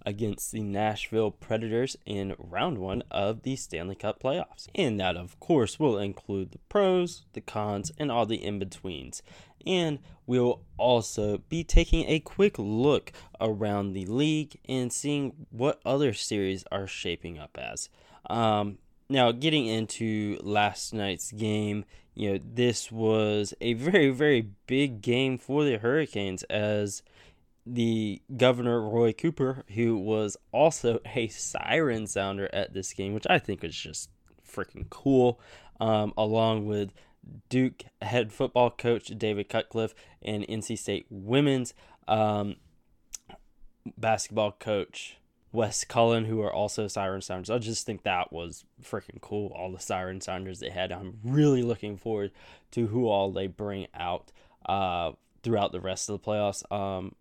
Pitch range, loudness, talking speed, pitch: 100-120 Hz, -29 LUFS, 150 wpm, 110 Hz